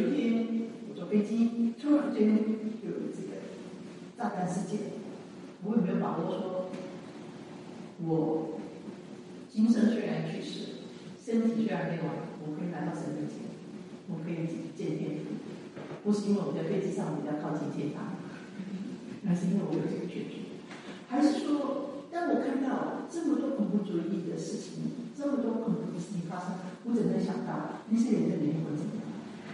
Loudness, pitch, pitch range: -32 LUFS, 210 Hz, 180-230 Hz